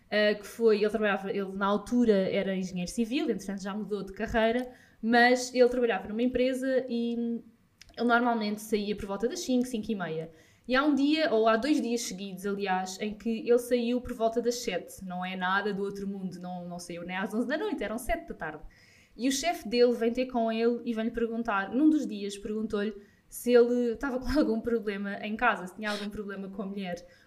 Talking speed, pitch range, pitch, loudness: 215 wpm, 200-240 Hz, 225 Hz, -29 LUFS